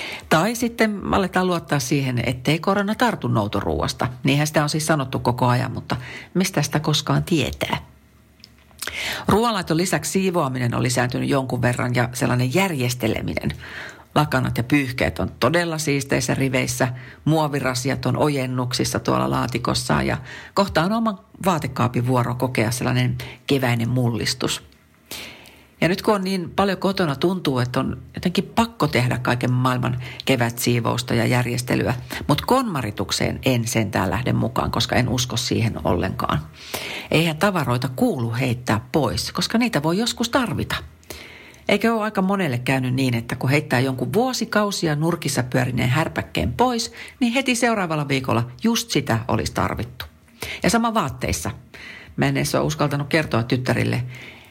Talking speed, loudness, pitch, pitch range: 140 wpm, -21 LUFS, 135 Hz, 125-175 Hz